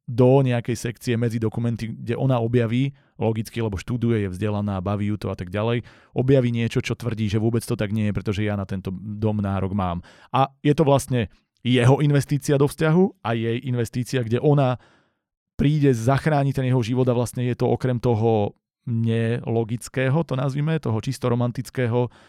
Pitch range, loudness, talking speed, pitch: 110-130 Hz, -23 LUFS, 180 wpm, 120 Hz